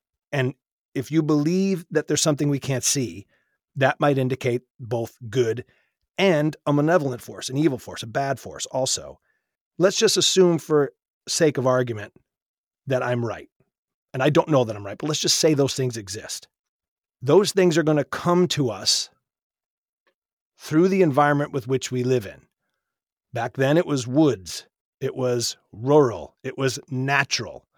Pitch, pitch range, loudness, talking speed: 135 Hz, 125-155 Hz, -22 LUFS, 165 wpm